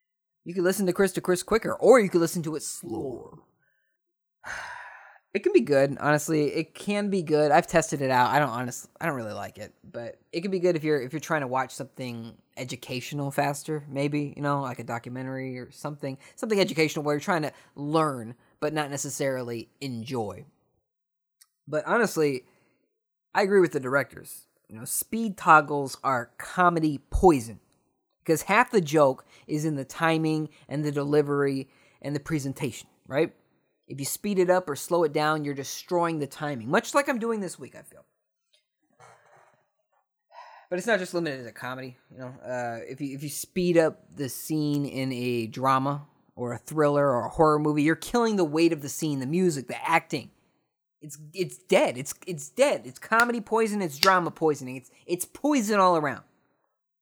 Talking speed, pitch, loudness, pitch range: 185 wpm, 150 Hz, -26 LUFS, 135-180 Hz